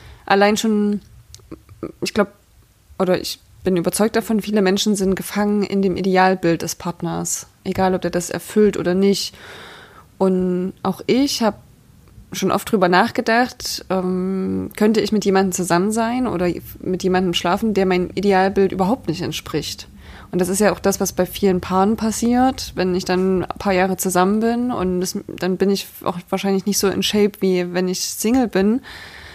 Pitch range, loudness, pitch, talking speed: 180-205 Hz, -19 LUFS, 190 Hz, 175 wpm